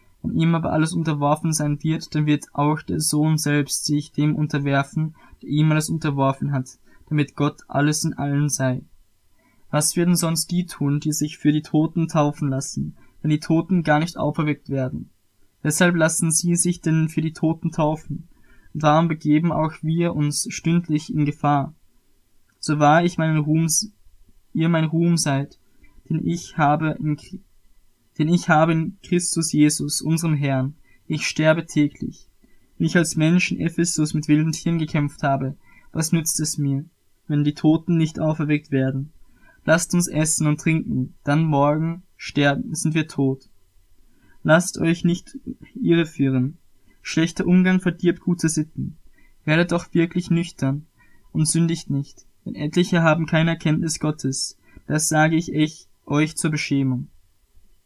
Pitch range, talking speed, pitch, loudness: 145-165 Hz, 155 wpm, 155 Hz, -21 LUFS